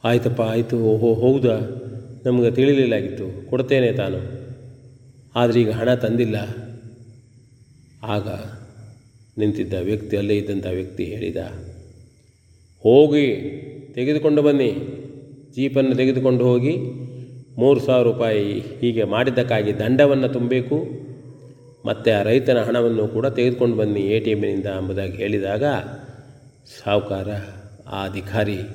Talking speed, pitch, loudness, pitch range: 100 wpm, 120 Hz, -20 LUFS, 105-130 Hz